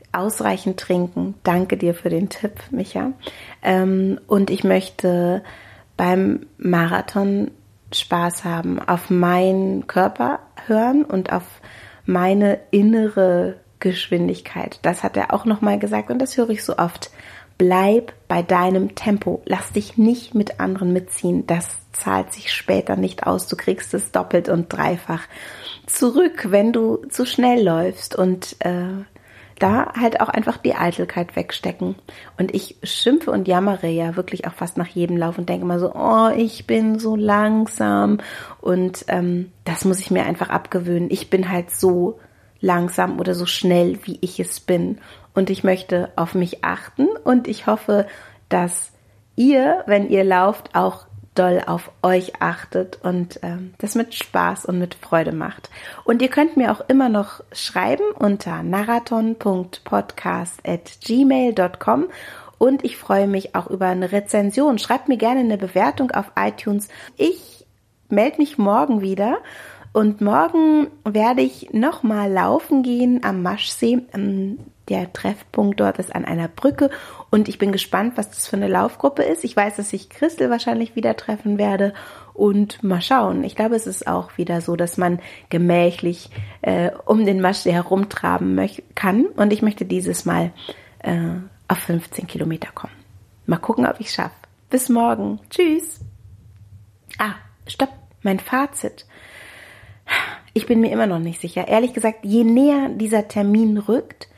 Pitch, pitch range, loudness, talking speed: 190 Hz, 175-225 Hz, -20 LUFS, 155 wpm